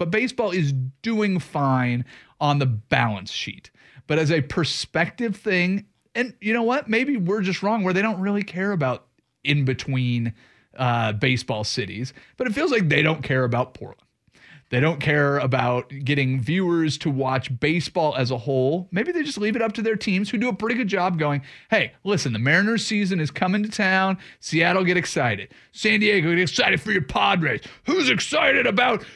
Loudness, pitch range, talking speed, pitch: -22 LUFS, 130-200 Hz, 190 wpm, 165 Hz